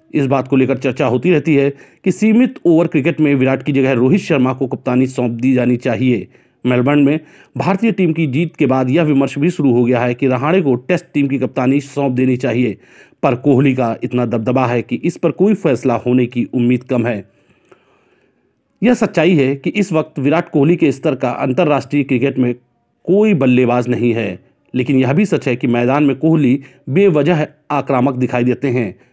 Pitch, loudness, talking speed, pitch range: 135 Hz, -15 LUFS, 200 wpm, 125-155 Hz